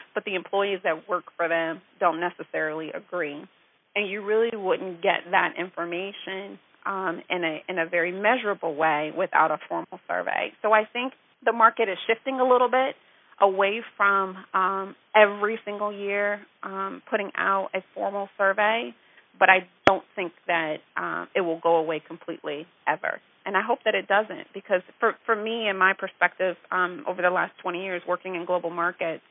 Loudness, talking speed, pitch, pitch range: -25 LUFS, 175 wpm, 190 Hz, 175-205 Hz